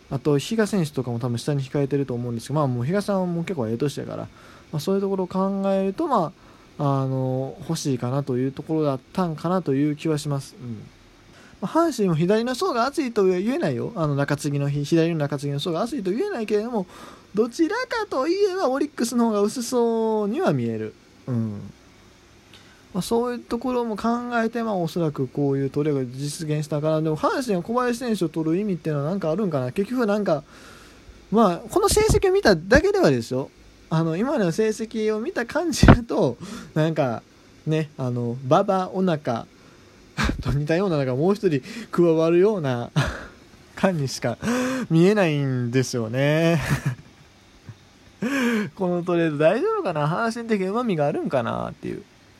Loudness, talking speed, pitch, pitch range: -23 LUFS, 365 characters per minute, 165 Hz, 140-215 Hz